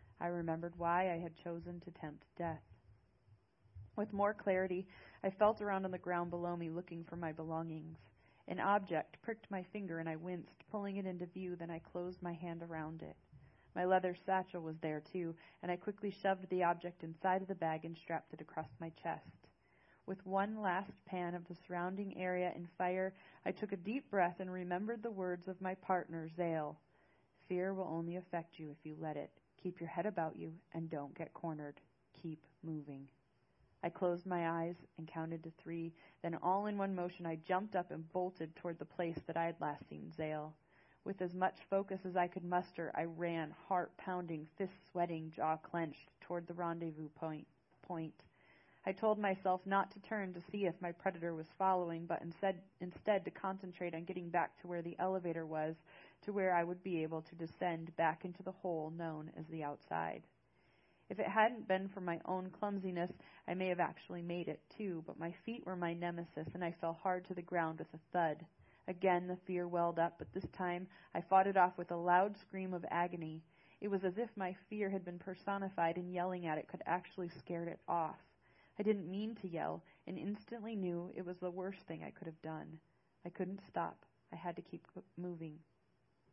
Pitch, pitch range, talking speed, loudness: 175 Hz, 165-185 Hz, 200 wpm, -41 LUFS